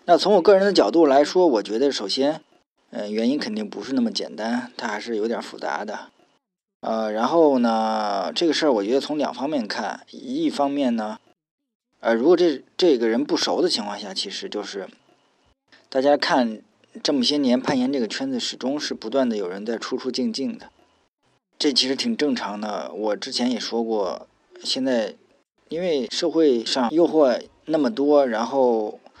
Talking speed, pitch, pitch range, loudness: 255 characters per minute, 145 Hz, 120-195 Hz, -22 LUFS